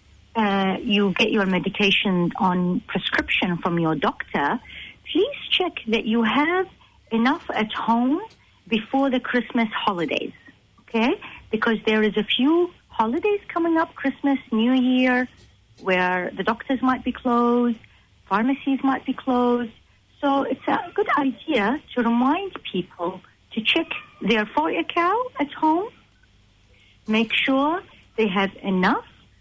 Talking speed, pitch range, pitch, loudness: 130 wpm, 210-285 Hz, 240 Hz, -22 LUFS